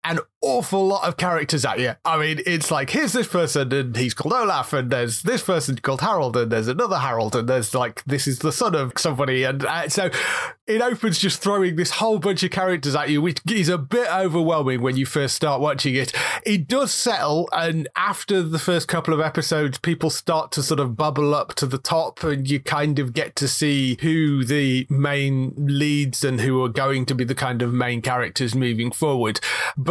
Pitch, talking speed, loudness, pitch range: 150 Hz, 215 wpm, -21 LUFS, 135-170 Hz